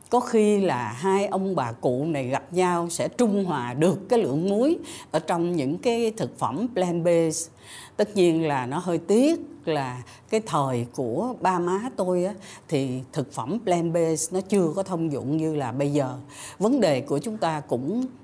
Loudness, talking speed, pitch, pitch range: -25 LUFS, 195 wpm, 175 Hz, 145-200 Hz